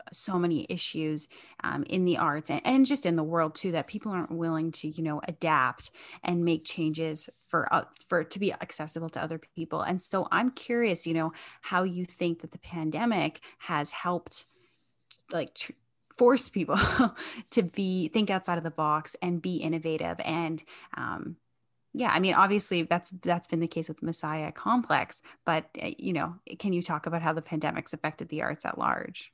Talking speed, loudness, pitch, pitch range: 190 wpm, -29 LUFS, 170 Hz, 160-185 Hz